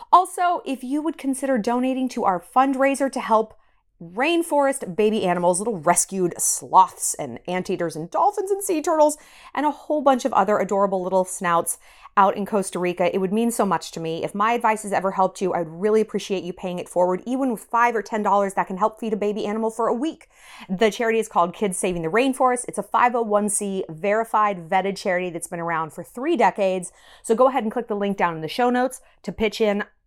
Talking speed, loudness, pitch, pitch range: 215 wpm, -22 LUFS, 210 Hz, 185-245 Hz